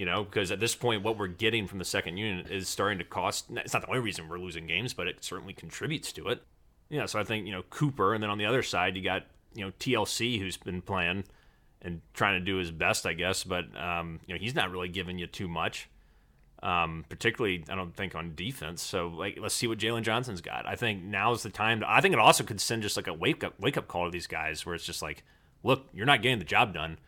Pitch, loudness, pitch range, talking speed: 95 Hz, -30 LUFS, 90-110 Hz, 270 wpm